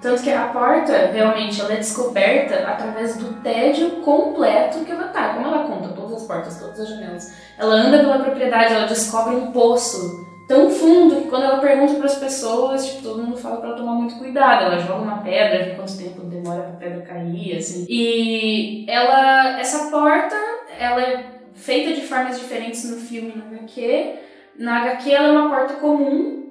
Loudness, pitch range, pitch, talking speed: -18 LUFS, 220-280 Hz, 245 Hz, 190 wpm